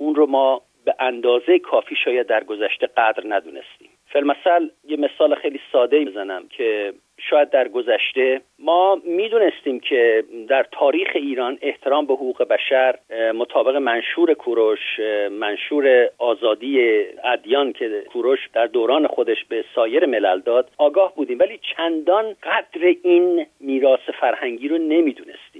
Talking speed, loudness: 130 wpm, -19 LUFS